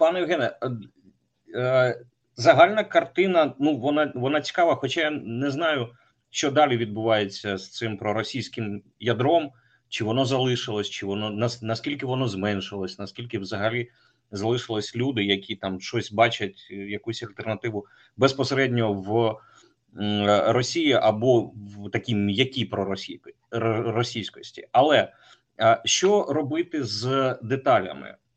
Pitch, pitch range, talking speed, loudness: 115 Hz, 105-135 Hz, 110 wpm, -24 LUFS